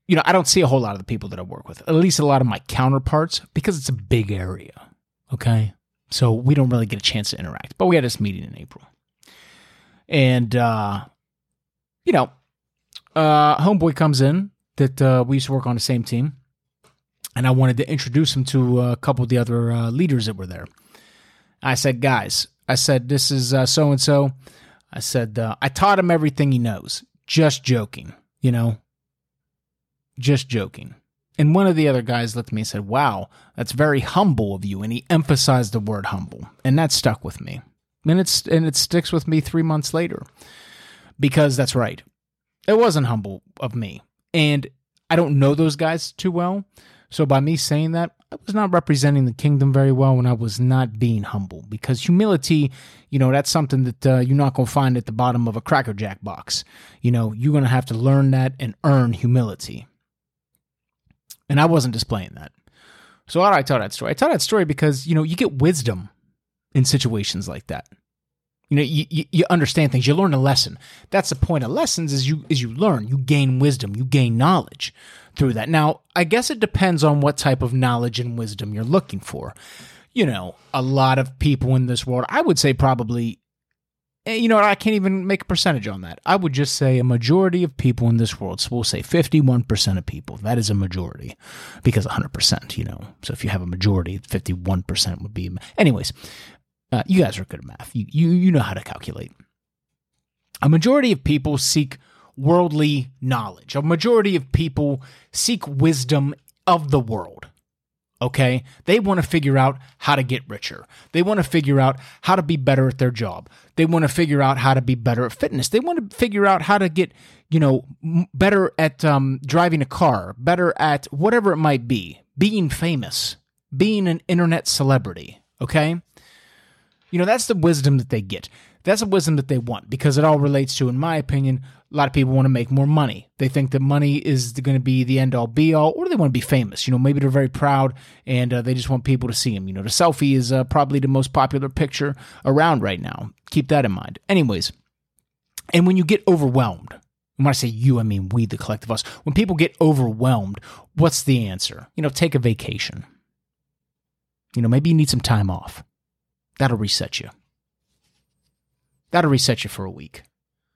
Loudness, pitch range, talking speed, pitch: -19 LUFS, 120-155 Hz, 210 wpm, 135 Hz